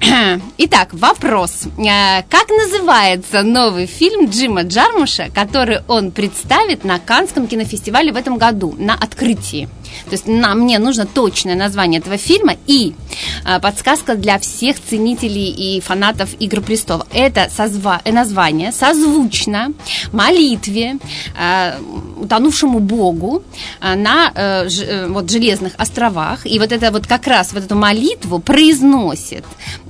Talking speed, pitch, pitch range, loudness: 110 wpm, 220 Hz, 195-265 Hz, -13 LUFS